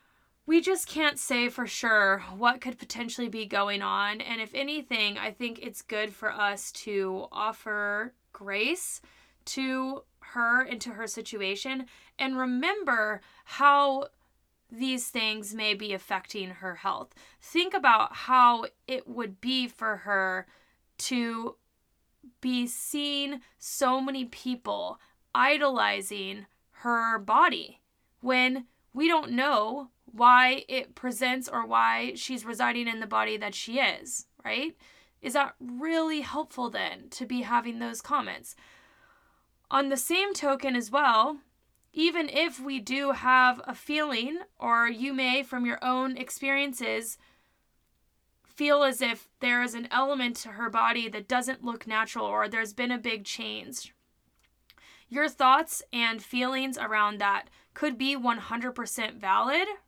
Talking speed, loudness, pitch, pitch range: 135 wpm, -28 LUFS, 250 Hz, 220-275 Hz